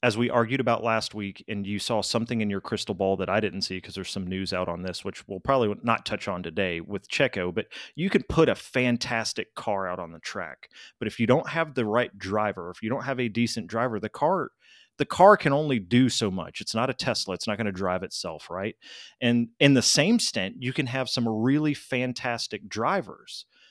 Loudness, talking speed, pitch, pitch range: -26 LUFS, 235 wpm, 115 Hz, 100-125 Hz